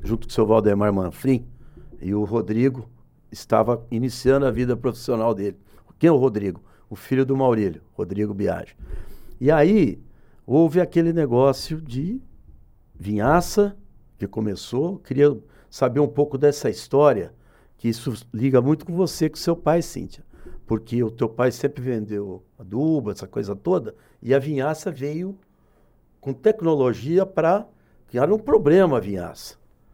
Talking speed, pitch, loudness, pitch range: 145 wpm, 130 Hz, -22 LUFS, 110-150 Hz